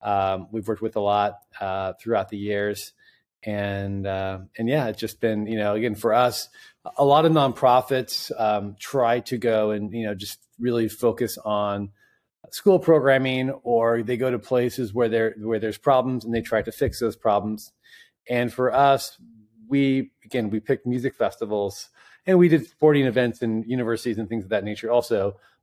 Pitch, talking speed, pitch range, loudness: 115 Hz, 185 wpm, 105-125 Hz, -23 LUFS